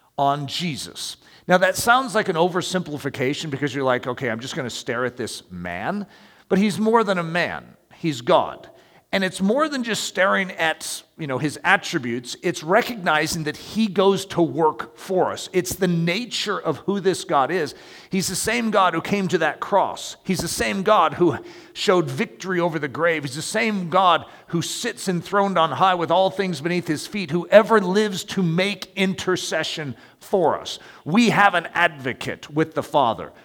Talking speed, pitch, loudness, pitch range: 185 wpm, 175 Hz, -21 LUFS, 155-200 Hz